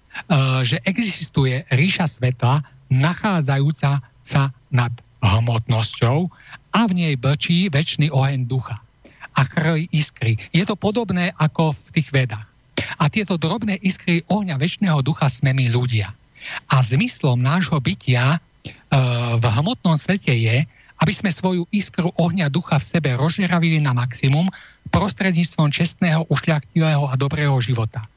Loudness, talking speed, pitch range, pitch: -20 LUFS, 130 wpm, 130-170 Hz, 150 Hz